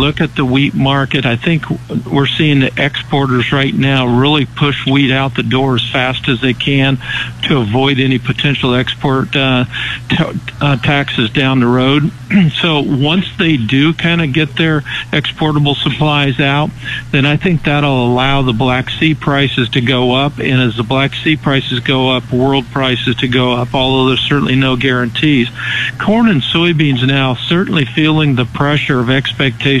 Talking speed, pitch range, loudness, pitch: 175 wpm, 130-150 Hz, -12 LUFS, 135 Hz